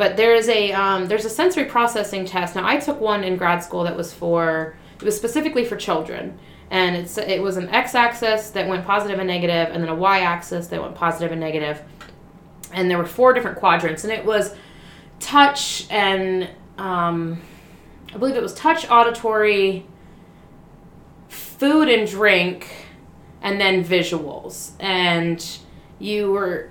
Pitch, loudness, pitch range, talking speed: 195 Hz, -19 LUFS, 175-220 Hz, 165 wpm